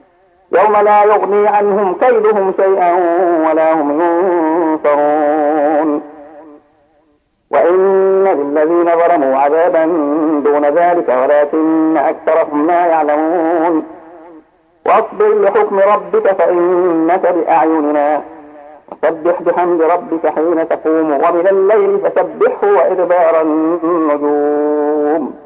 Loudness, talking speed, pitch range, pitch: -12 LUFS, 80 wpm, 150-180 Hz, 165 Hz